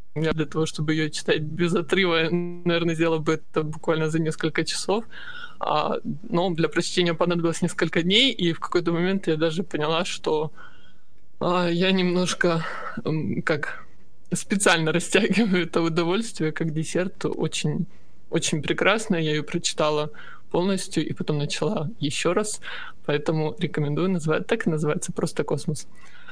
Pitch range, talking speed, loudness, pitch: 155-180 Hz, 140 wpm, -24 LUFS, 170 Hz